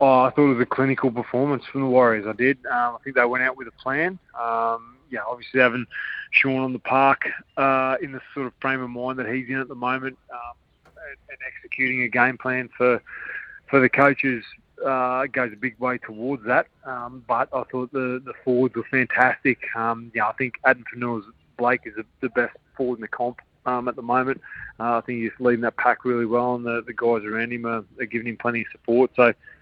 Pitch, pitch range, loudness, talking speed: 125 Hz, 120-130 Hz, -23 LUFS, 230 wpm